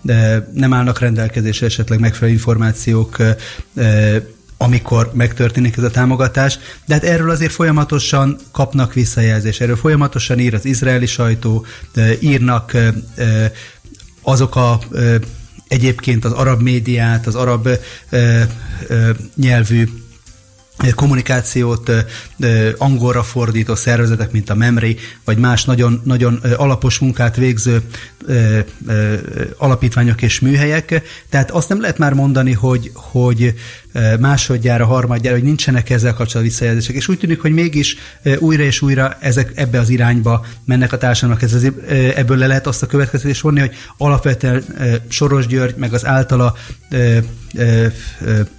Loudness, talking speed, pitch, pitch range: -14 LUFS, 120 wpm, 120 Hz, 115-130 Hz